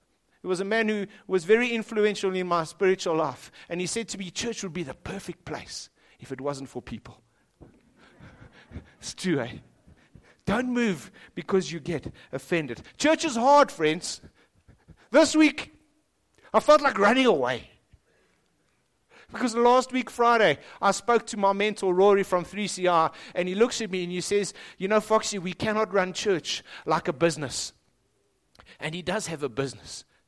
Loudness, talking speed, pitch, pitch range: -25 LUFS, 165 wpm, 190 Hz, 165-220 Hz